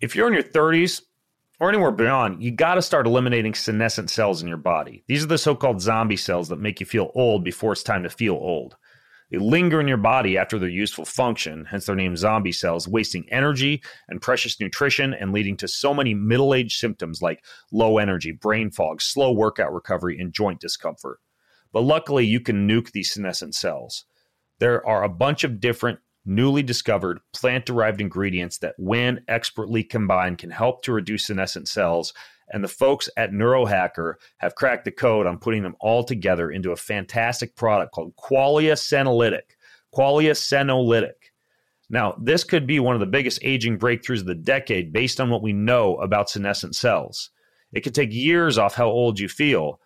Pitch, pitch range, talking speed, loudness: 115 Hz, 100-130 Hz, 185 wpm, -22 LUFS